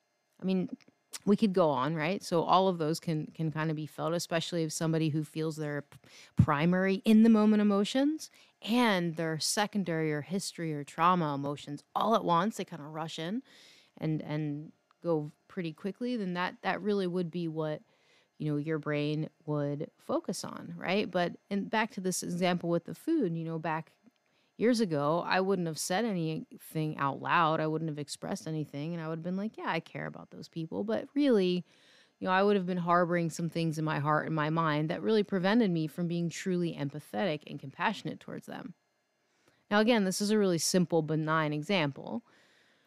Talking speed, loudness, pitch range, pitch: 195 wpm, -31 LUFS, 155-200 Hz, 170 Hz